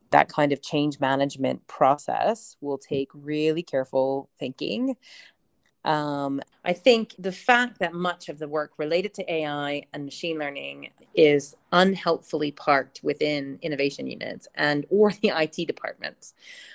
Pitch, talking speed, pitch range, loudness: 150 Hz, 135 wpm, 140-175 Hz, -25 LUFS